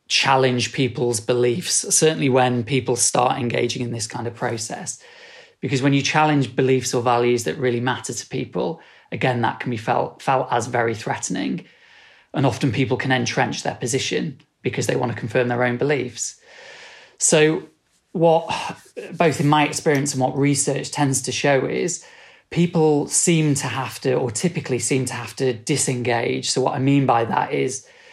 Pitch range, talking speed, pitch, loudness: 125-155 Hz, 175 wpm, 135 Hz, -20 LUFS